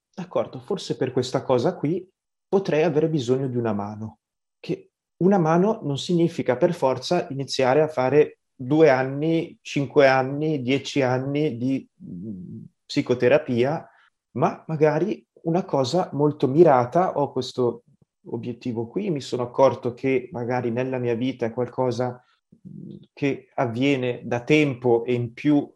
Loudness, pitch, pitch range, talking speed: -23 LUFS, 135 Hz, 125-160 Hz, 135 wpm